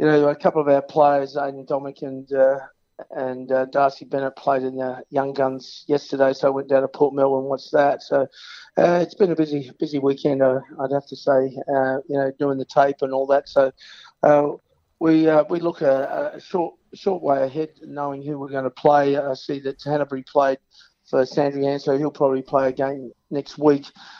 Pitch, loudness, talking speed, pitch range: 140 Hz, -21 LUFS, 210 wpm, 135-145 Hz